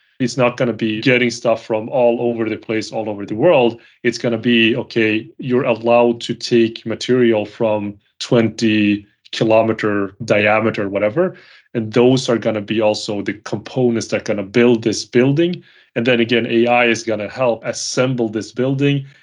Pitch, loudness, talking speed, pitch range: 115 Hz, -17 LUFS, 180 wpm, 110-120 Hz